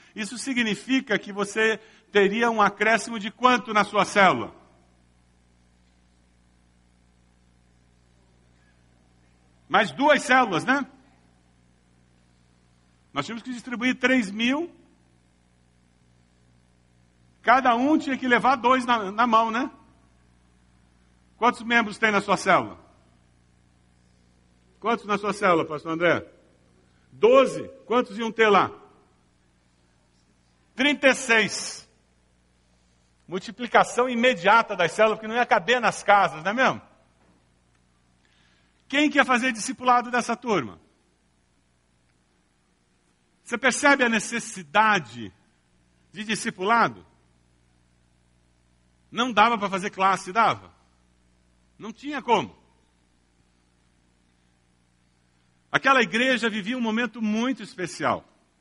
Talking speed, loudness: 95 wpm, -22 LUFS